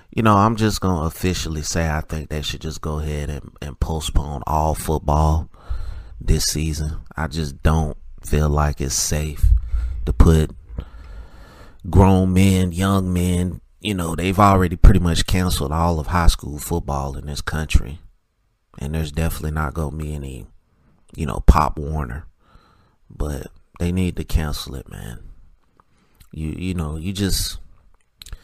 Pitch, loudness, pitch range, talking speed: 80 Hz, -21 LUFS, 75-90 Hz, 150 wpm